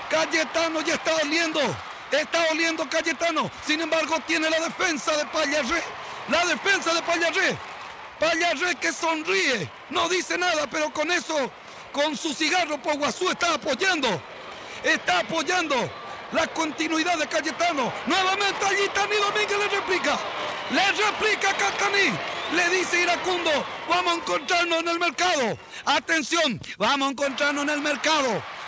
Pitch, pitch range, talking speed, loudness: 330 Hz, 310-355 Hz, 135 wpm, -23 LUFS